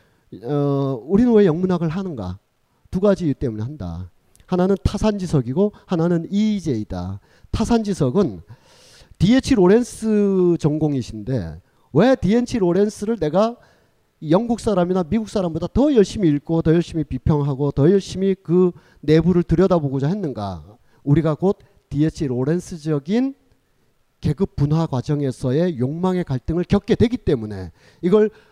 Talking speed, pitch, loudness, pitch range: 295 characters per minute, 170 Hz, -20 LUFS, 140-200 Hz